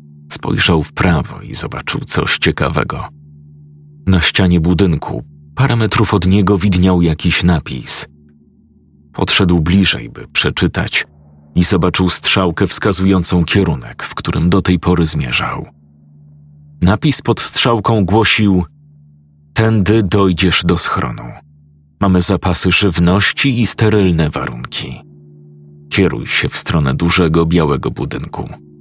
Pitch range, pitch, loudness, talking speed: 75-95 Hz, 85 Hz, -13 LUFS, 110 wpm